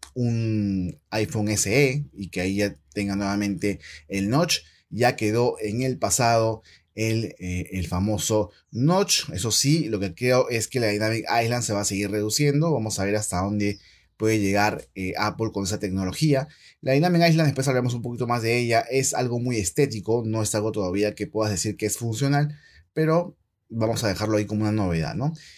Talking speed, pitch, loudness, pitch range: 190 wpm, 110 Hz, -24 LUFS, 100-125 Hz